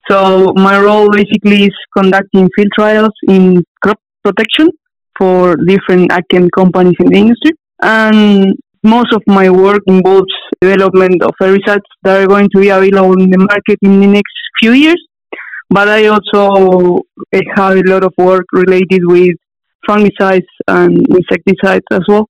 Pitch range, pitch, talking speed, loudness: 185-210 Hz, 195 Hz, 150 wpm, -8 LUFS